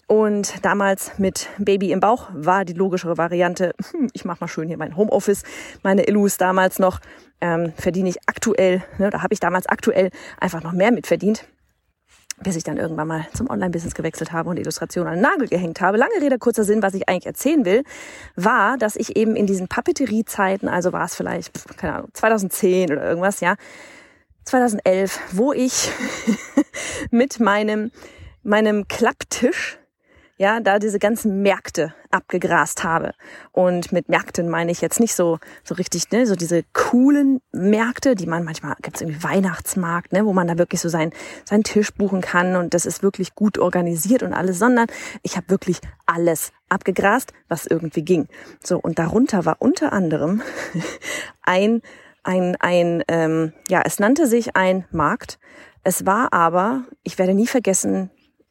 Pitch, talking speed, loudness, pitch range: 190 Hz, 175 wpm, -20 LUFS, 175-220 Hz